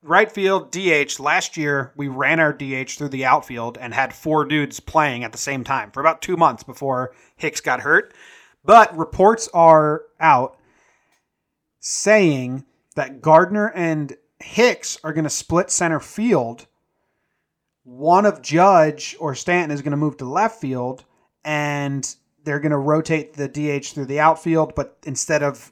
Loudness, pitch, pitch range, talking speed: -19 LUFS, 150 Hz, 140-165 Hz, 160 wpm